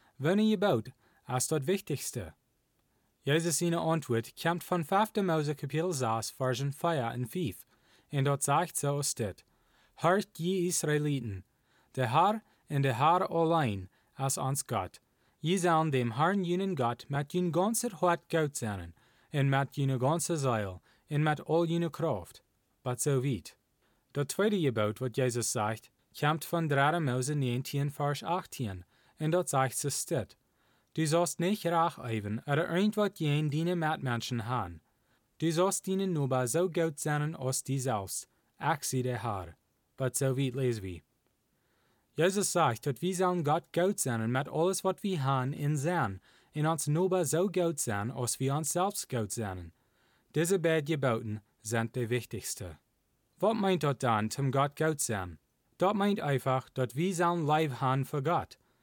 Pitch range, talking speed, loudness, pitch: 125-170 Hz, 165 wpm, -31 LUFS, 140 Hz